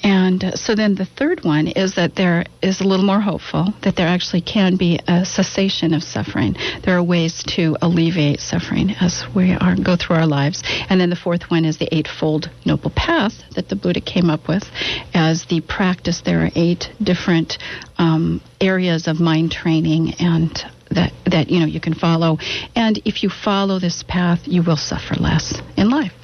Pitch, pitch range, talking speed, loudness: 175 Hz, 160-190 Hz, 190 wpm, -18 LUFS